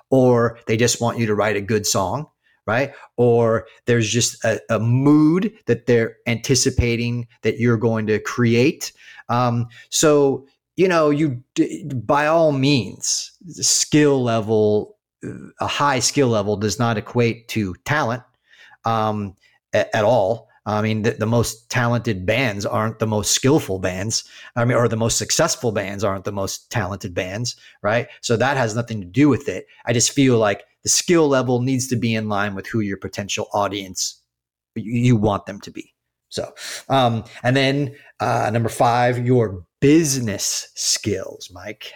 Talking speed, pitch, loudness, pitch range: 165 wpm, 120 Hz, -19 LUFS, 110-130 Hz